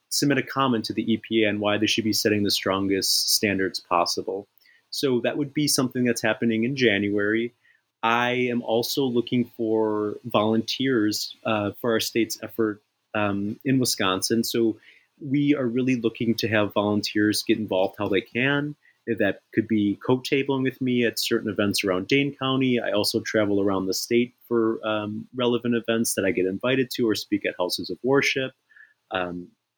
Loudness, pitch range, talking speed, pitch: -24 LUFS, 105-125 Hz, 175 wpm, 115 Hz